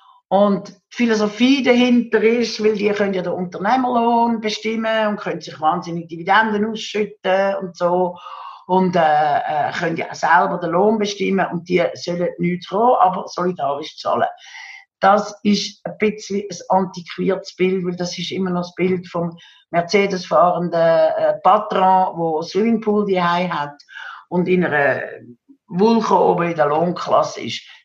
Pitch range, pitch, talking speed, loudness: 175-215 Hz, 190 Hz, 140 wpm, -18 LUFS